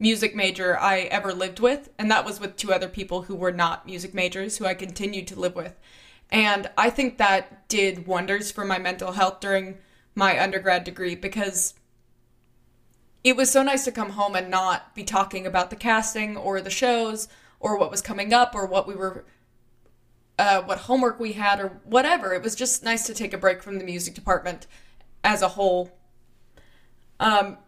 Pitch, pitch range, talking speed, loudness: 195 Hz, 185-215 Hz, 190 wpm, -24 LUFS